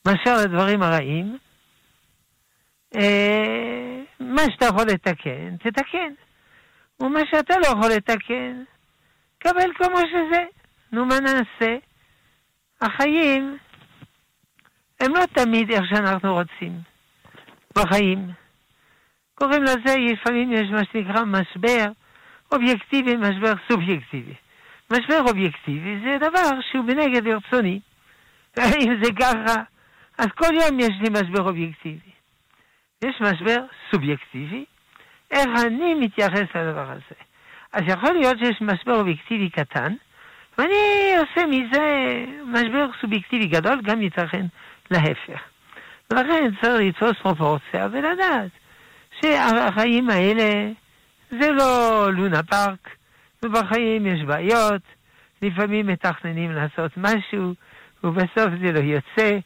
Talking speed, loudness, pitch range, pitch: 100 wpm, -21 LUFS, 190-260 Hz, 225 Hz